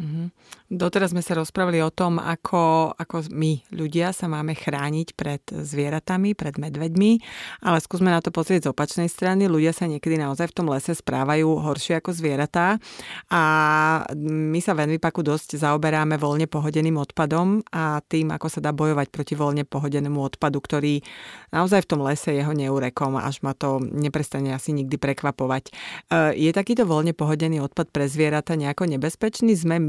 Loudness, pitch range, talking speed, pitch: -23 LUFS, 145-170 Hz, 165 wpm, 155 Hz